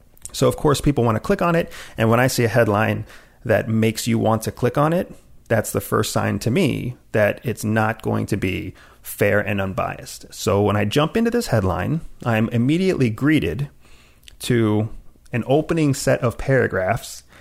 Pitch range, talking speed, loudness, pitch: 105-135 Hz, 185 wpm, -20 LUFS, 115 Hz